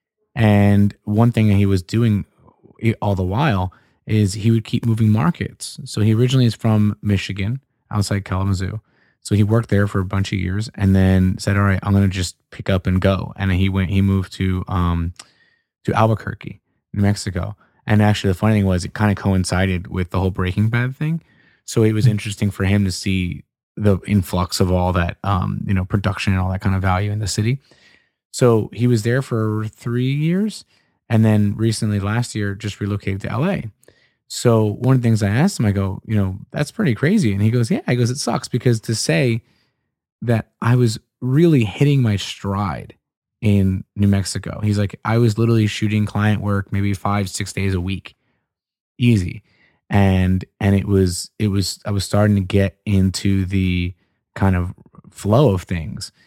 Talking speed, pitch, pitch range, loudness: 195 wpm, 105 Hz, 95-115 Hz, -19 LUFS